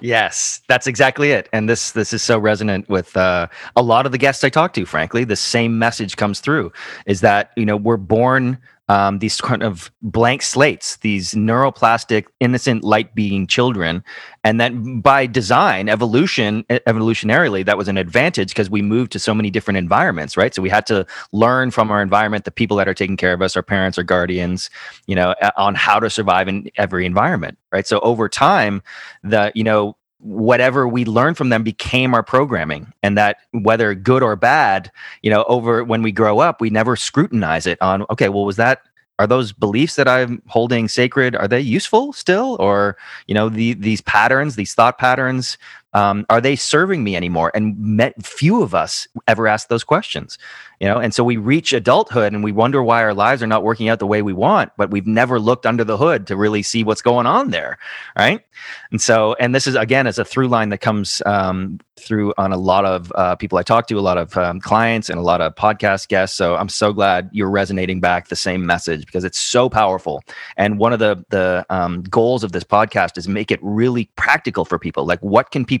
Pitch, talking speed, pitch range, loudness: 110 Hz, 215 wpm, 100-120 Hz, -16 LUFS